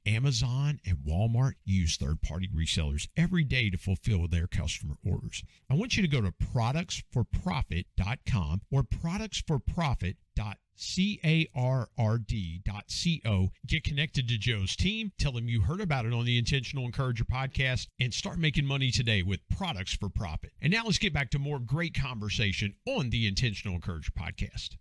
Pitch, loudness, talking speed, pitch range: 115 Hz, -31 LUFS, 150 wpm, 95-140 Hz